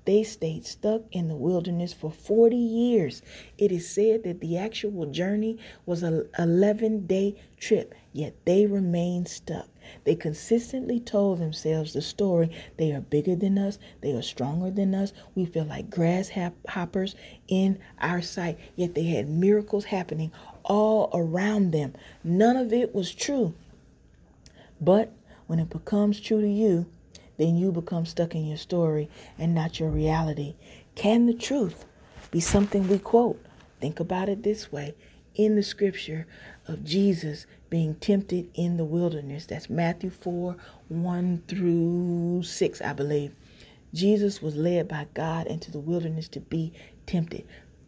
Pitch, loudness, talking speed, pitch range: 175 Hz, -27 LUFS, 150 wpm, 160-200 Hz